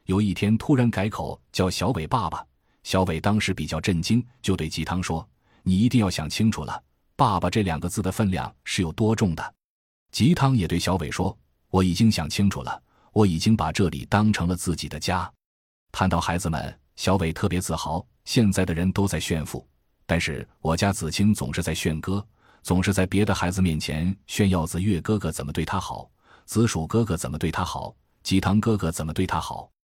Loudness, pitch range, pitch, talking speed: -24 LUFS, 80-105 Hz, 95 Hz, 285 characters per minute